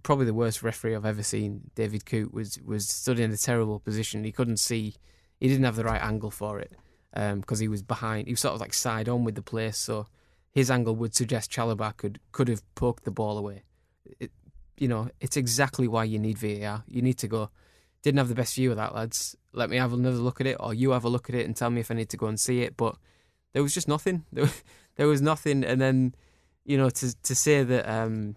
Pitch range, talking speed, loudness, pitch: 110-125 Hz, 255 wpm, -28 LUFS, 115 Hz